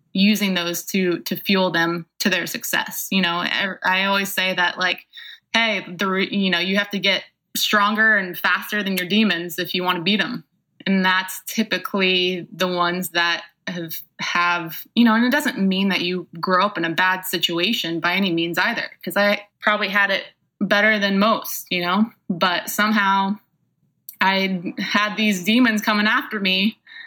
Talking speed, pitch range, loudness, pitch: 180 wpm, 180-210 Hz, -20 LUFS, 195 Hz